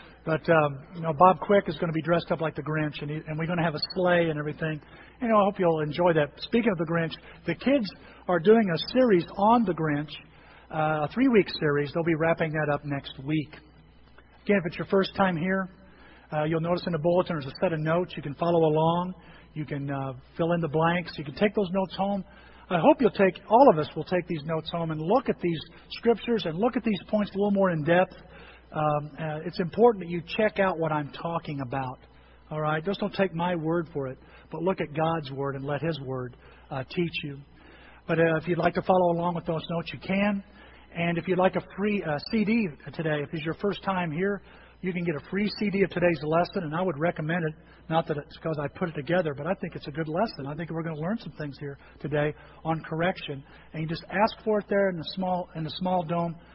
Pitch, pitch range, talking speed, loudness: 170 Hz, 155-190 Hz, 250 wpm, -27 LUFS